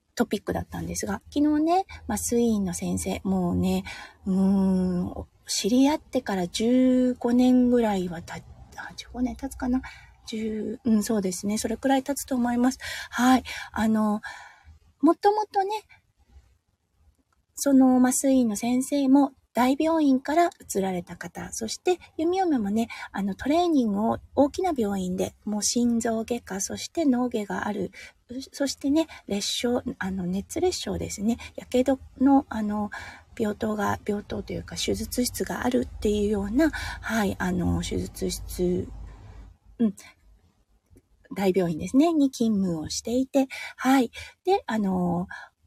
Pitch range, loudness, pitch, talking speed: 180-265 Hz, -25 LUFS, 225 Hz, 260 characters per minute